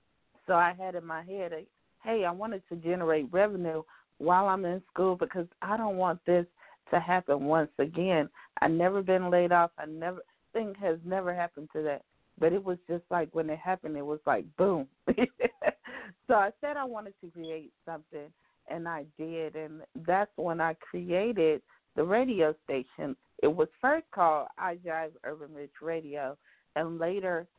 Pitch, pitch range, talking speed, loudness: 175 Hz, 160-190 Hz, 175 wpm, -31 LUFS